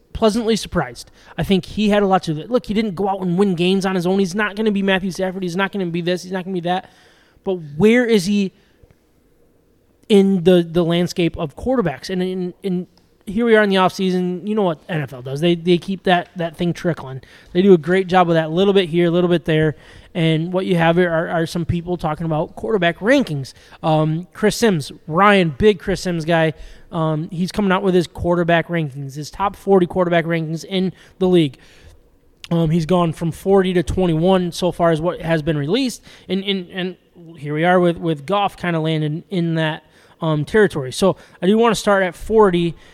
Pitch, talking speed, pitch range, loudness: 180 Hz, 220 wpm, 165-195 Hz, -18 LUFS